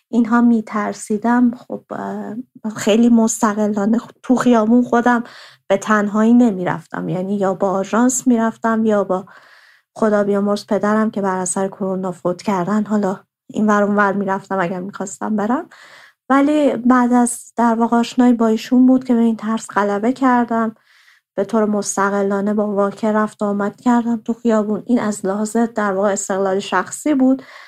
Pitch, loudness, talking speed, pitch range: 215 Hz, -17 LUFS, 145 wpm, 200-235 Hz